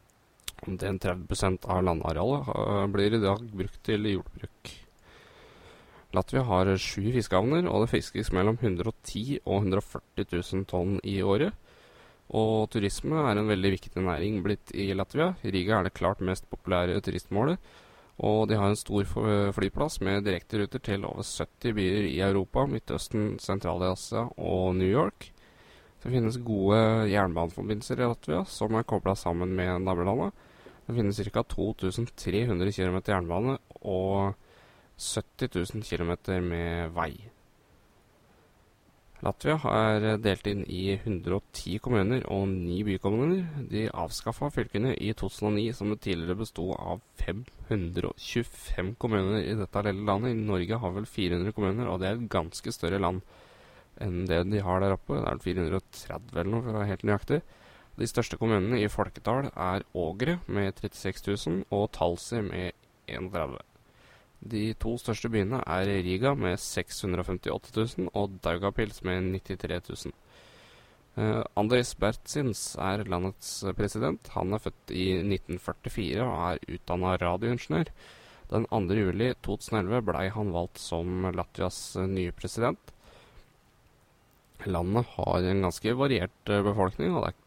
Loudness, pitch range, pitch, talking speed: -30 LUFS, 90-110 Hz, 100 Hz, 140 wpm